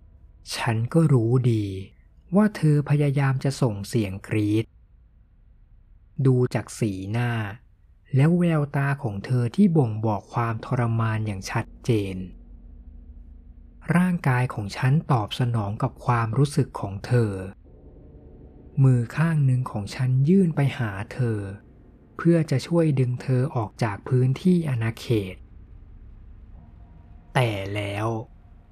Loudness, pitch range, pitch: -24 LUFS, 95-130 Hz, 115 Hz